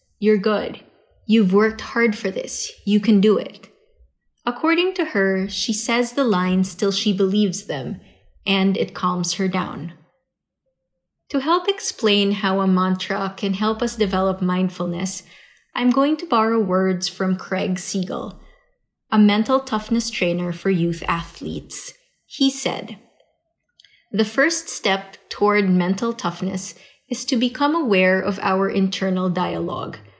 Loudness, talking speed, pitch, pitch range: -20 LUFS, 135 wpm, 200 Hz, 185-230 Hz